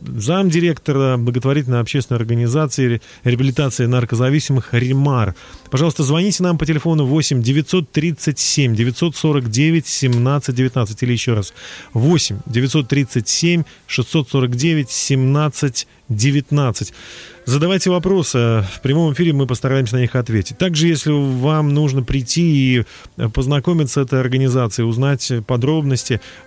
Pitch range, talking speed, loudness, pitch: 125-155 Hz, 90 wpm, -17 LUFS, 135 Hz